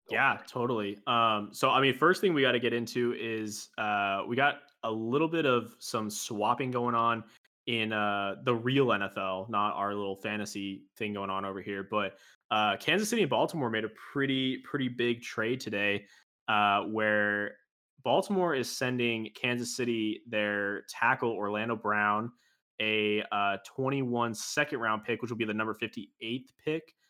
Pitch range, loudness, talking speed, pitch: 105-125 Hz, -30 LUFS, 170 wpm, 115 Hz